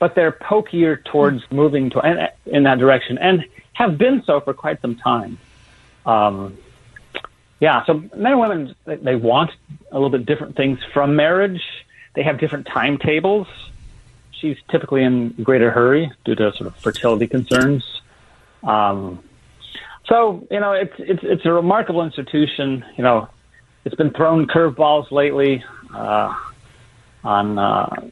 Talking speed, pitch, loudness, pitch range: 145 wpm, 140 Hz, -18 LUFS, 120-160 Hz